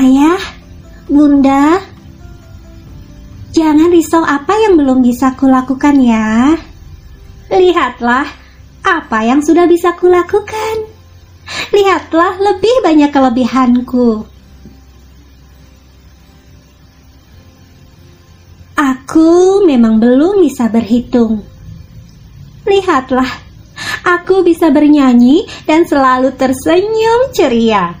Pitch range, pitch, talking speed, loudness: 225-345 Hz, 270 Hz, 70 wpm, -10 LUFS